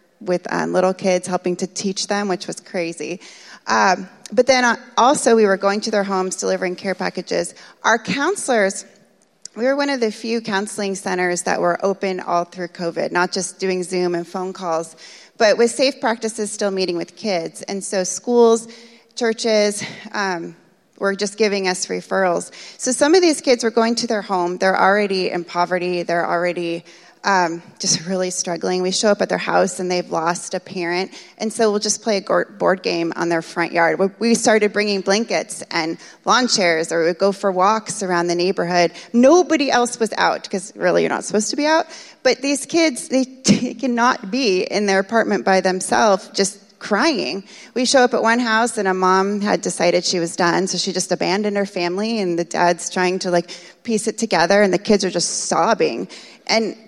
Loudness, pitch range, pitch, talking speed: -19 LUFS, 180-225 Hz, 195 Hz, 195 wpm